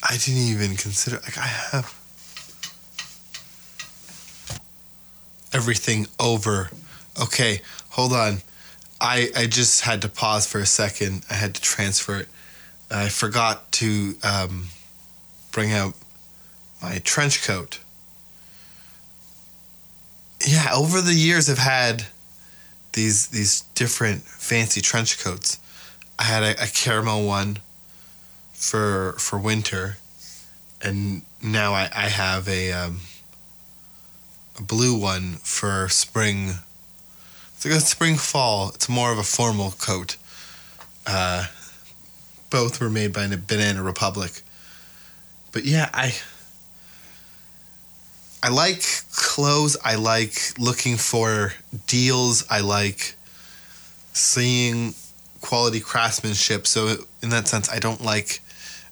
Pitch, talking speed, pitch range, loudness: 105 Hz, 110 wpm, 95-120 Hz, -21 LUFS